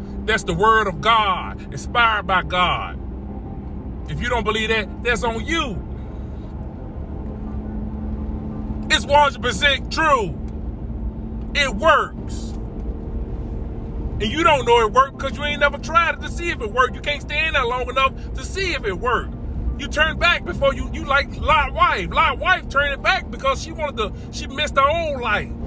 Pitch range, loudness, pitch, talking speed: 195-280 Hz, -20 LUFS, 240 Hz, 170 wpm